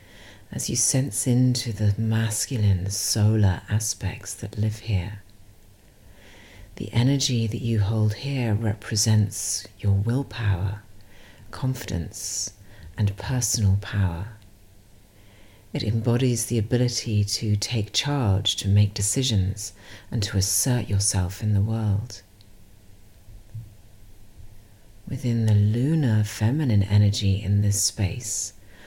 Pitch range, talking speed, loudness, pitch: 100-115 Hz, 100 wpm, -24 LUFS, 105 Hz